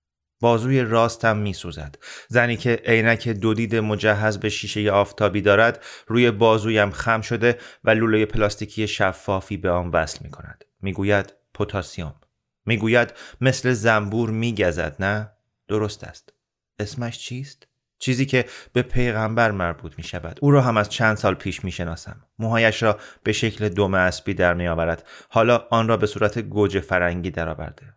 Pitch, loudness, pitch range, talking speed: 105 Hz, -21 LUFS, 95-115 Hz, 155 wpm